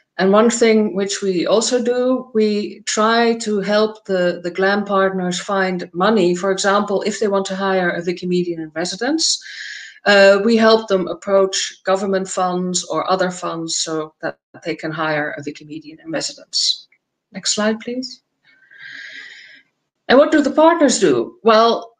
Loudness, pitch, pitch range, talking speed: -17 LUFS, 195 Hz, 180-220 Hz, 155 wpm